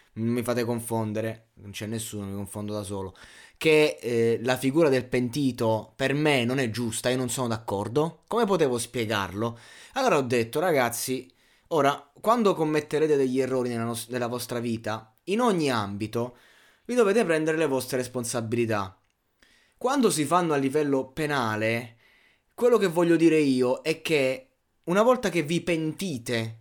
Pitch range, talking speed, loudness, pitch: 115-155 Hz, 160 wpm, -26 LUFS, 125 Hz